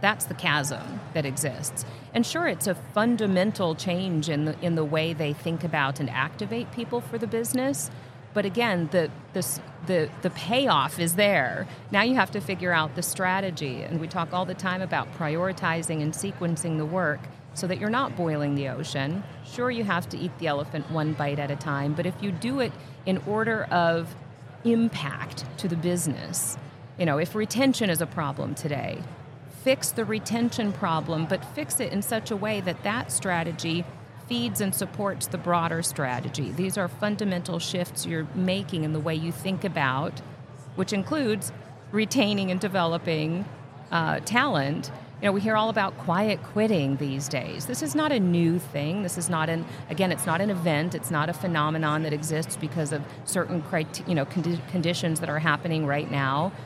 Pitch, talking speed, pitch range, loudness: 165 Hz, 185 wpm, 145-190 Hz, -27 LUFS